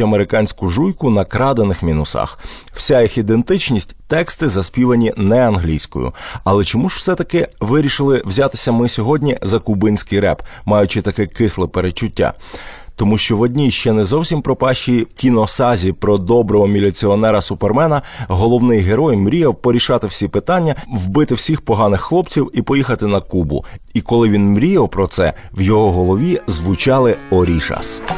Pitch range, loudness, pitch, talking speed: 100-125 Hz, -15 LUFS, 110 Hz, 140 wpm